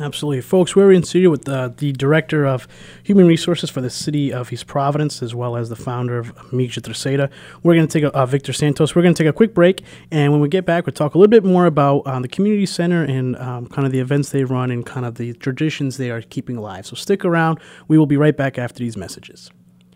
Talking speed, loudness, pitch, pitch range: 255 wpm, -17 LUFS, 140 Hz, 125-165 Hz